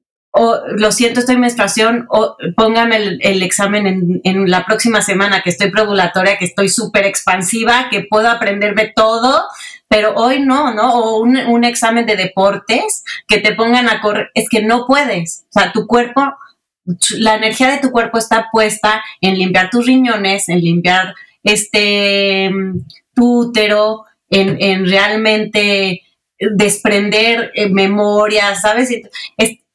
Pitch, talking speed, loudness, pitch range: 215 Hz, 145 wpm, -12 LUFS, 195-230 Hz